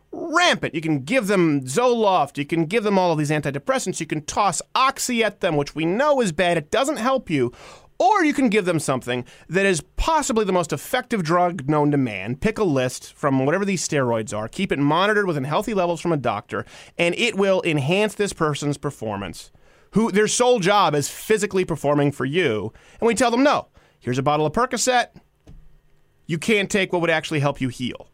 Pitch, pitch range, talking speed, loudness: 170 Hz, 145-215 Hz, 205 wpm, -21 LUFS